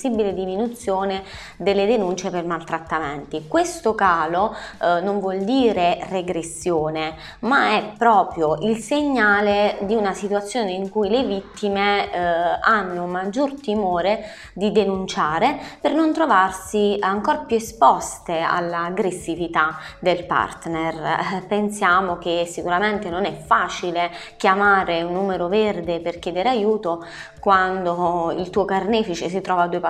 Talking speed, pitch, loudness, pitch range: 120 wpm, 190 Hz, -21 LUFS, 175-210 Hz